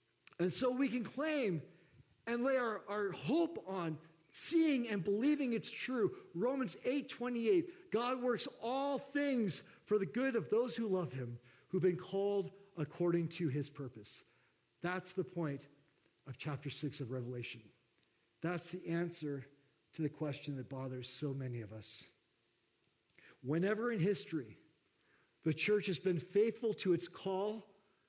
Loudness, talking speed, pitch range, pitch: -38 LUFS, 145 wpm, 145-230 Hz, 185 Hz